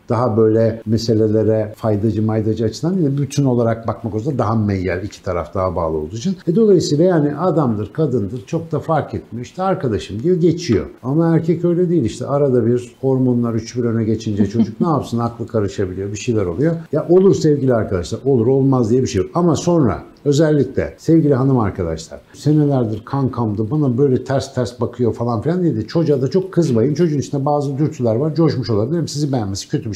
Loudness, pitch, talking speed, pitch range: -17 LUFS, 125 Hz, 190 wpm, 110-150 Hz